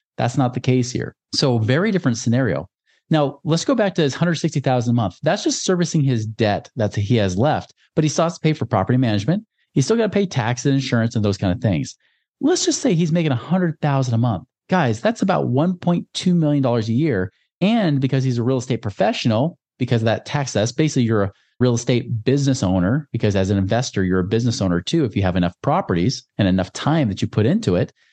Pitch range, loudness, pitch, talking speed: 110-155 Hz, -20 LUFS, 125 Hz, 225 wpm